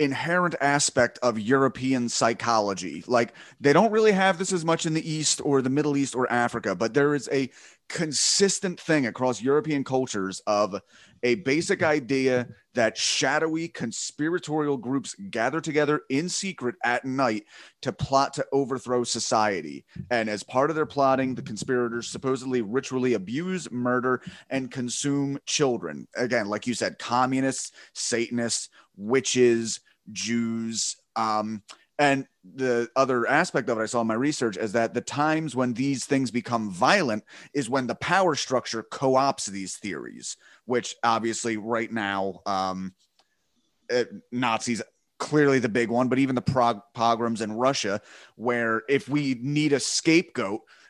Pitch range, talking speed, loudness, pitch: 115-145 Hz, 150 wpm, -25 LUFS, 130 Hz